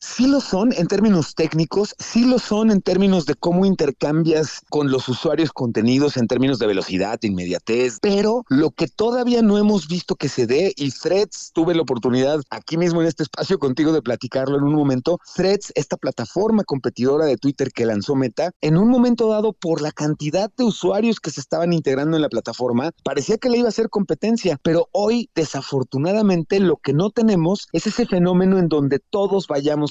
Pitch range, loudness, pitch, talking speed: 140-200 Hz, -19 LUFS, 165 Hz, 190 wpm